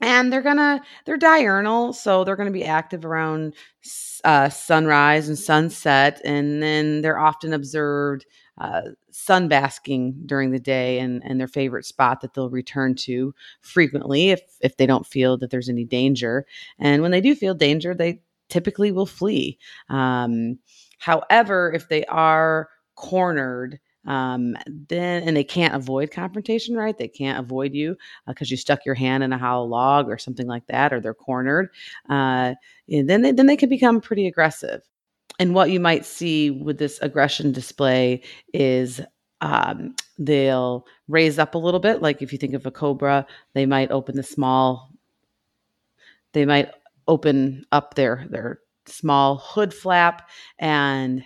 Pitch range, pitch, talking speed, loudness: 135-175 Hz, 145 Hz, 165 wpm, -21 LUFS